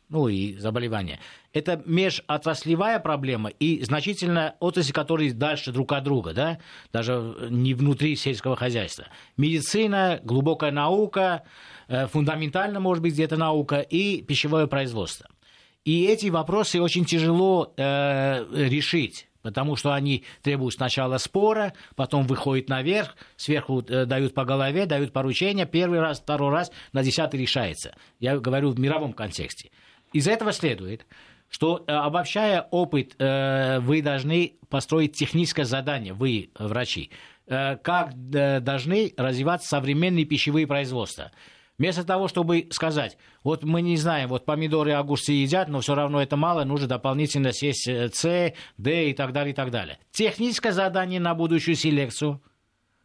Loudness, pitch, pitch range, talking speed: -25 LUFS, 145 Hz, 130-165 Hz, 135 wpm